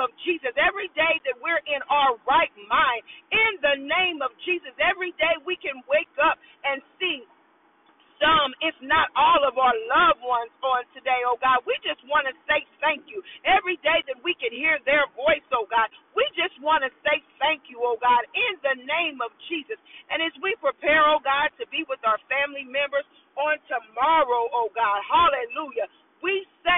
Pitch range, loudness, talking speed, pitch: 265-330 Hz, -23 LUFS, 185 wpm, 300 Hz